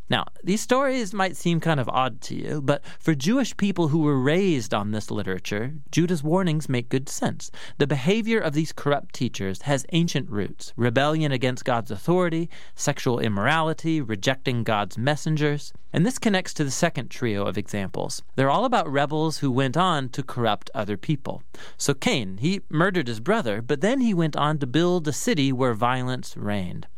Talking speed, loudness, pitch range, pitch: 180 wpm, -24 LUFS, 125-165 Hz, 145 Hz